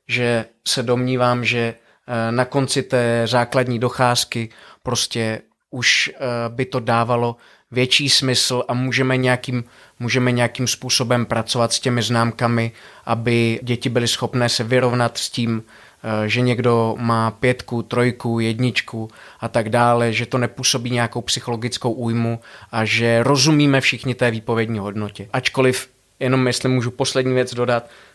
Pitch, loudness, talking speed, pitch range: 120 Hz, -19 LUFS, 135 wpm, 115-125 Hz